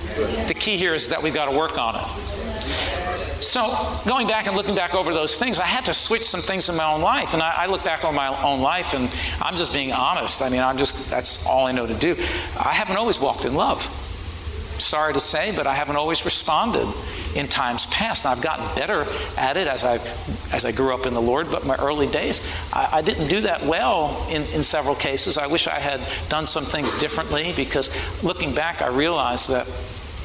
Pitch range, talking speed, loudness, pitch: 115-180 Hz, 225 wpm, -21 LUFS, 140 Hz